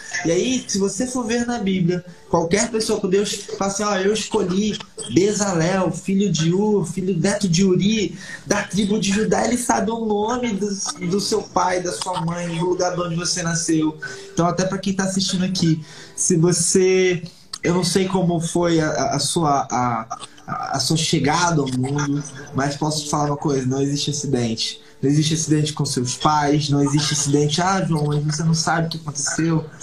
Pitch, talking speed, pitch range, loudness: 175 Hz, 190 wpm, 155-195 Hz, -20 LUFS